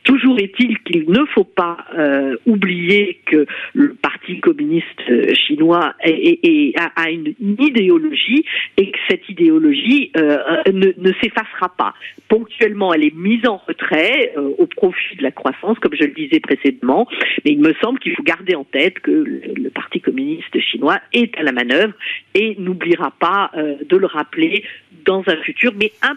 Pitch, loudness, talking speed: 225 Hz, -16 LUFS, 175 wpm